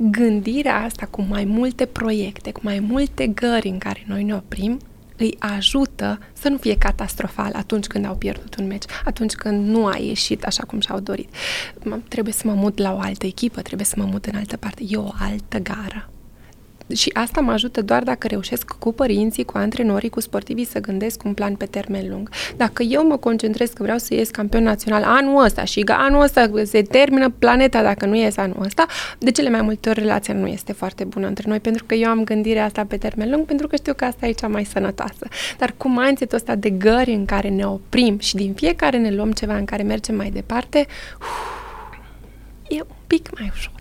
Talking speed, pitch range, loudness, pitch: 215 wpm, 205-250 Hz, -20 LUFS, 220 Hz